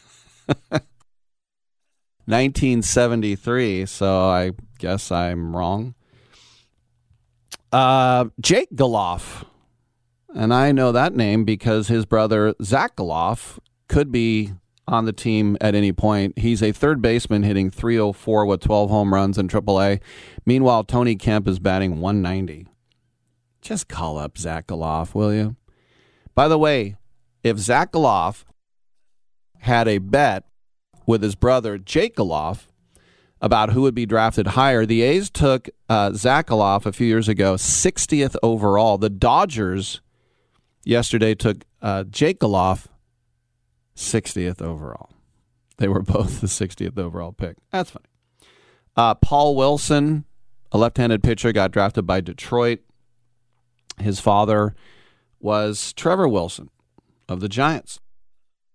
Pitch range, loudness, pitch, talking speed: 100-120 Hz, -20 LUFS, 110 Hz, 125 wpm